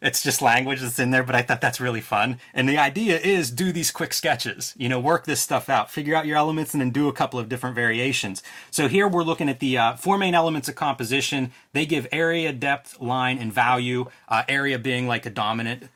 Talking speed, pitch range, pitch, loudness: 235 wpm, 125-150 Hz, 135 Hz, -23 LUFS